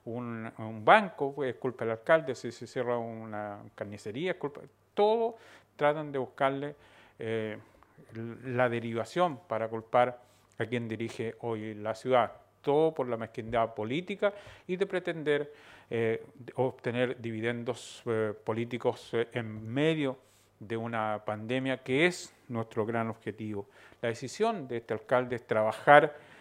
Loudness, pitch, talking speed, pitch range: -31 LUFS, 120 Hz, 140 wpm, 110-135 Hz